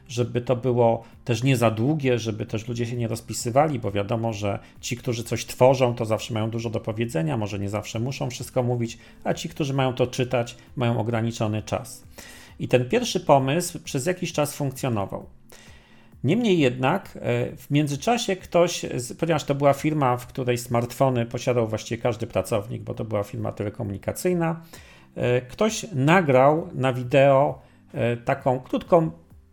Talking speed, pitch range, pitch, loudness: 155 wpm, 115-145 Hz, 125 Hz, -24 LUFS